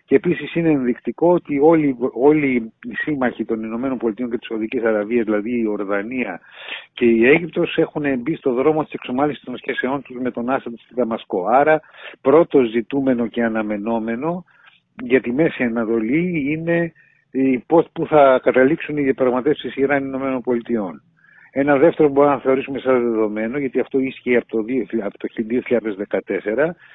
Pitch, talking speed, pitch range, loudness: 130 Hz, 150 wpm, 115-150 Hz, -19 LUFS